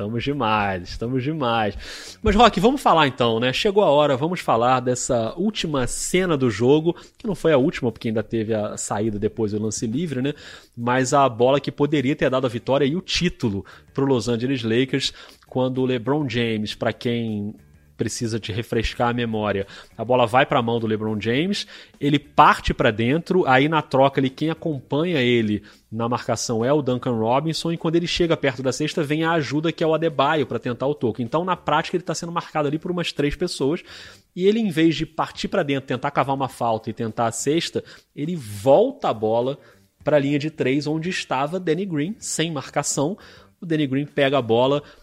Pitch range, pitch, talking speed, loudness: 115-155 Hz, 135 Hz, 210 wpm, -22 LUFS